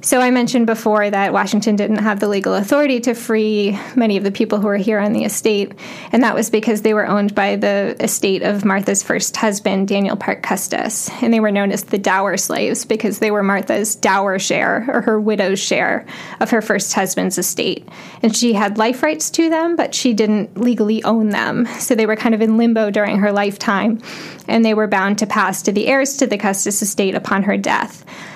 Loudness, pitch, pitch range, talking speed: -16 LUFS, 215 Hz, 200-230 Hz, 215 wpm